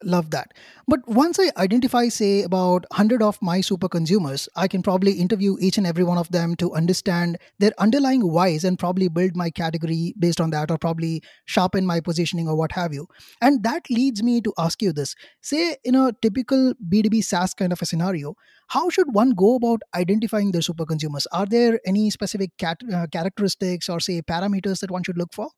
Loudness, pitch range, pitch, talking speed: -21 LUFS, 175-220 Hz, 190 Hz, 200 wpm